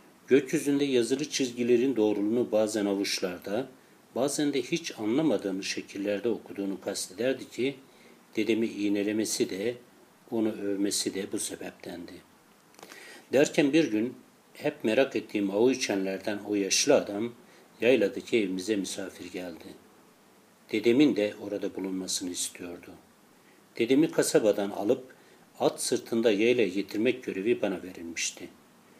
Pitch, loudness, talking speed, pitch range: 105 Hz, -28 LUFS, 110 wpm, 100-120 Hz